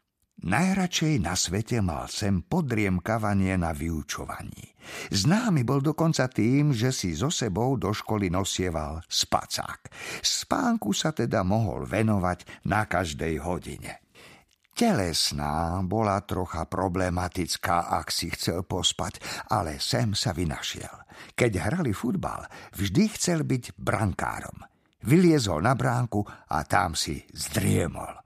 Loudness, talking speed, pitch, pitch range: -26 LUFS, 115 wpm, 100 Hz, 90-125 Hz